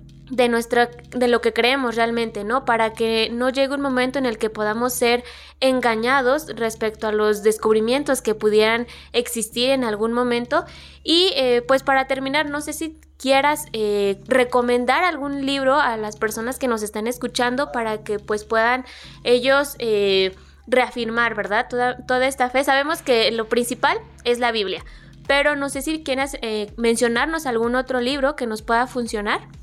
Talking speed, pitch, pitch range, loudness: 170 wpm, 245 Hz, 225-270 Hz, -20 LUFS